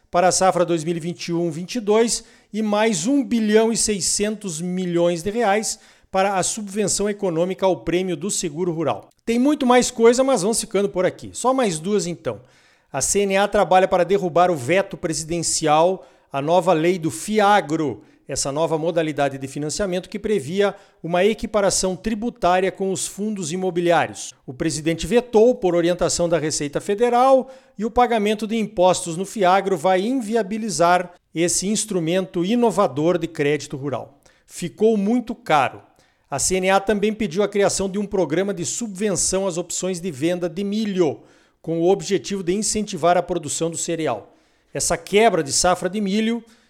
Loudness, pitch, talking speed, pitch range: -20 LUFS, 185 Hz, 155 wpm, 175-215 Hz